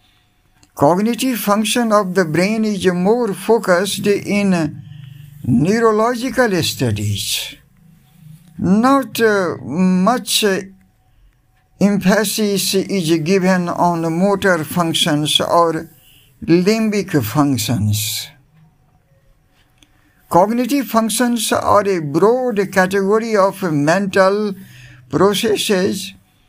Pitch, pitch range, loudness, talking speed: 180 Hz, 145-205 Hz, -16 LUFS, 70 wpm